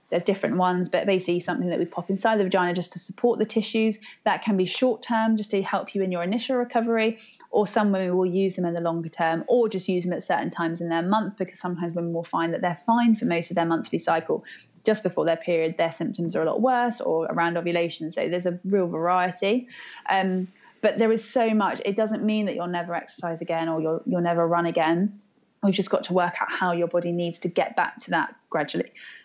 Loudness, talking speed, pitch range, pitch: -25 LUFS, 240 wpm, 170-215 Hz, 185 Hz